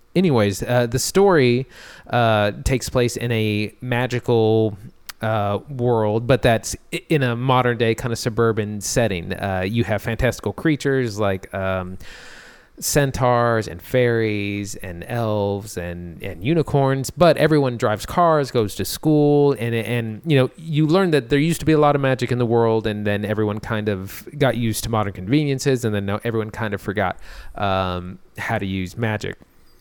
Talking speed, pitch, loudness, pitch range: 165 wpm, 115 Hz, -20 LUFS, 105-130 Hz